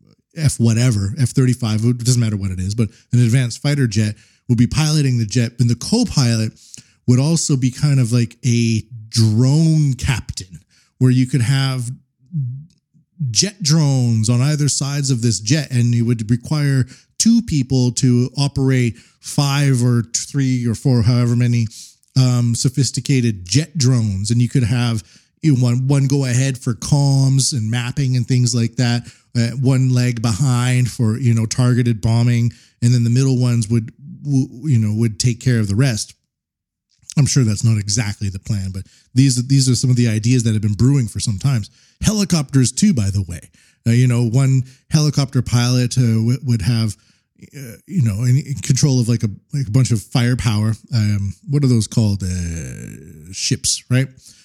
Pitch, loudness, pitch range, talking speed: 125 Hz, -17 LUFS, 115-135 Hz, 180 wpm